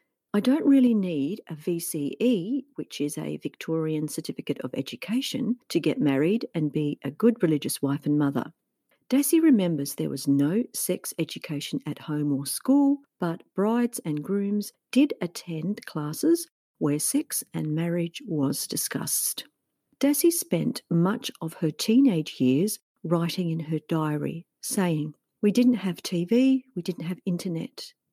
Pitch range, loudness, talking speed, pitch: 150-240 Hz, -26 LUFS, 145 wpm, 175 Hz